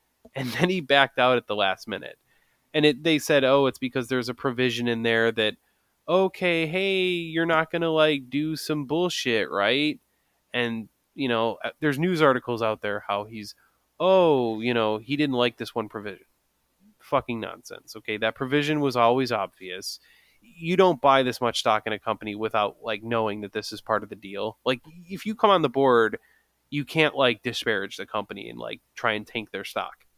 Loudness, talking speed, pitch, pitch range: -24 LUFS, 195 wpm, 130 Hz, 110-155 Hz